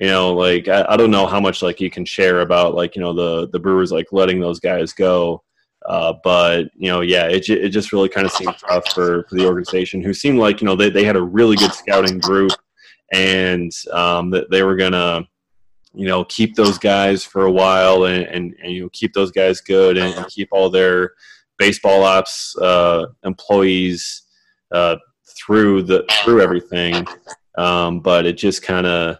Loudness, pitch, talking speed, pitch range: -16 LUFS, 95 Hz, 200 wpm, 90-95 Hz